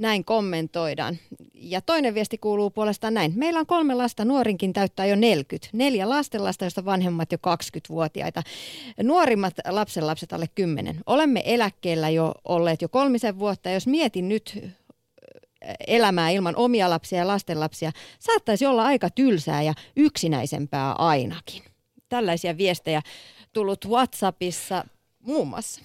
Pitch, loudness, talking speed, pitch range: 195 Hz, -24 LUFS, 130 wpm, 170-235 Hz